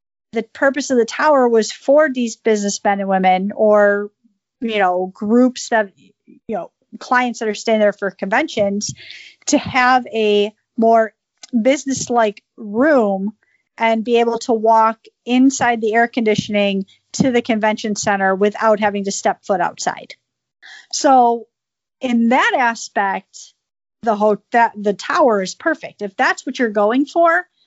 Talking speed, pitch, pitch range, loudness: 150 wpm, 225 Hz, 205-255 Hz, -17 LUFS